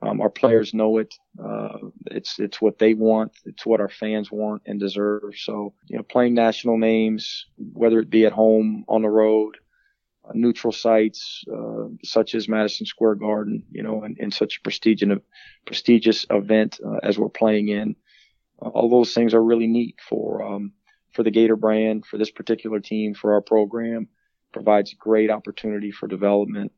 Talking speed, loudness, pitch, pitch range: 185 wpm, -21 LUFS, 110 Hz, 105-115 Hz